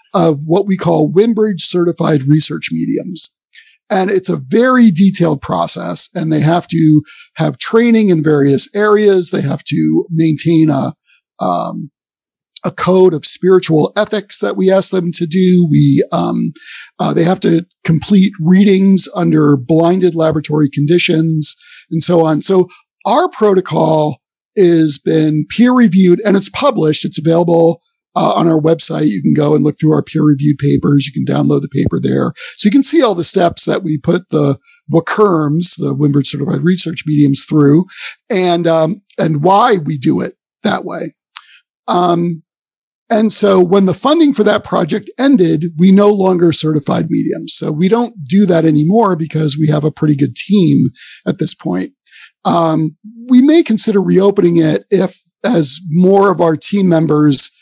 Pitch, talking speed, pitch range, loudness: 170 Hz, 165 wpm, 155-195 Hz, -12 LUFS